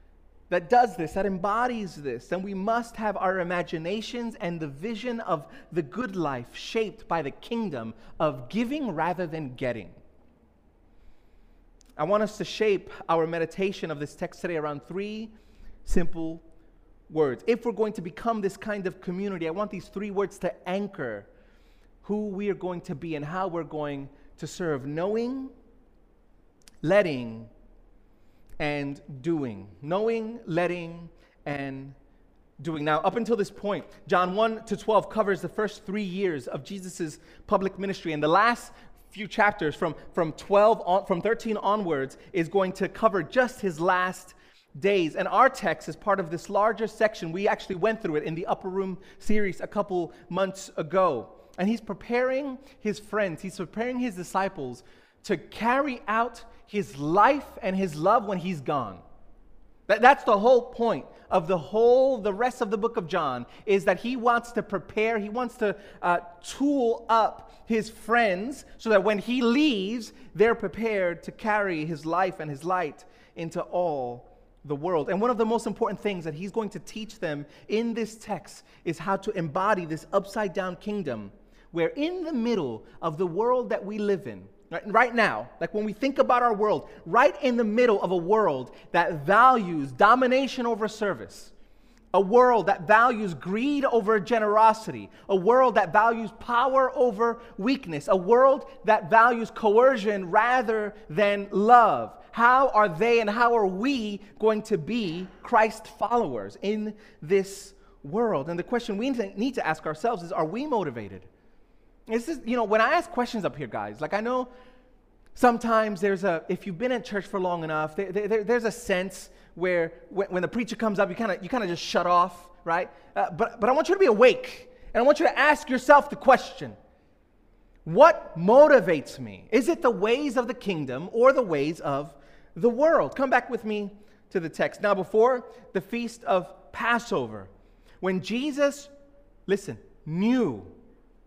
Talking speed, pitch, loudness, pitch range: 175 wpm, 205 Hz, -26 LUFS, 175-230 Hz